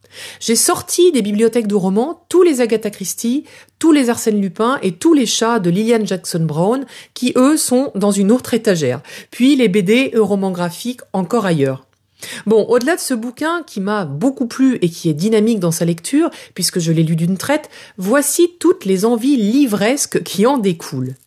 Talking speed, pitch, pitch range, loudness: 190 wpm, 230 Hz, 190-265 Hz, -15 LUFS